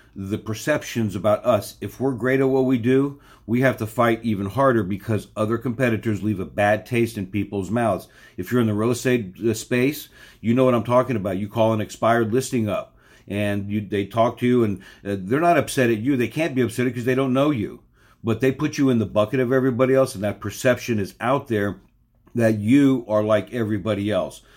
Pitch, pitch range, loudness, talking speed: 115 Hz, 105-130 Hz, -22 LUFS, 215 wpm